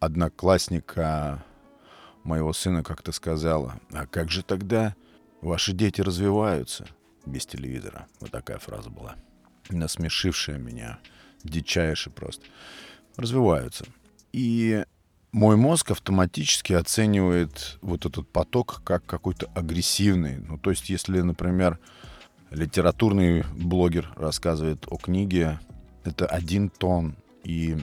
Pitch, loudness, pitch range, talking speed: 85 Hz, -25 LUFS, 80-95 Hz, 105 wpm